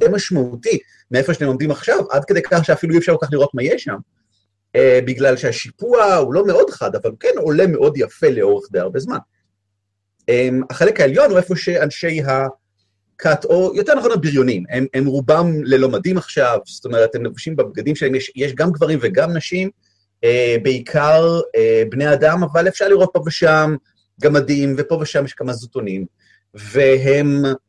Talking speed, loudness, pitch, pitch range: 165 wpm, -16 LUFS, 145 Hz, 125-175 Hz